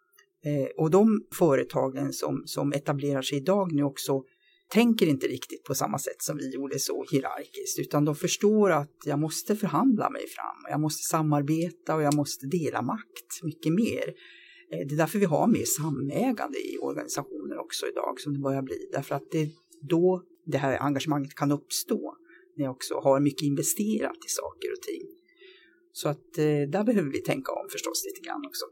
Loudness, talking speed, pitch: -28 LUFS, 190 wpm, 170 Hz